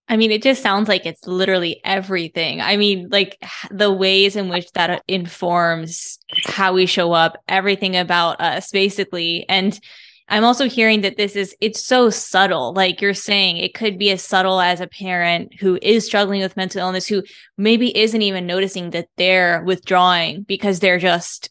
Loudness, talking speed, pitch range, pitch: -17 LUFS, 180 wpm, 180-205 Hz, 190 Hz